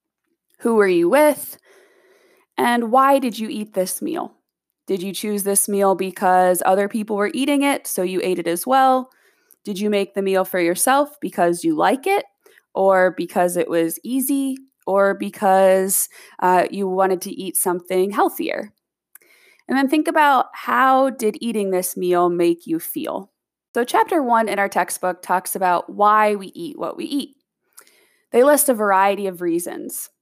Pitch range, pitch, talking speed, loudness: 185-280 Hz, 210 Hz, 170 wpm, -19 LUFS